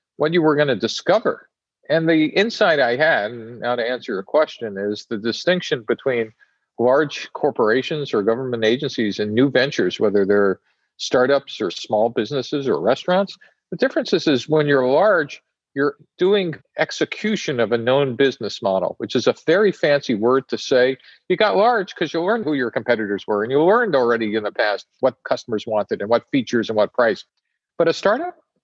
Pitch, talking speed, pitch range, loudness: 130 Hz, 185 wpm, 115-155 Hz, -20 LUFS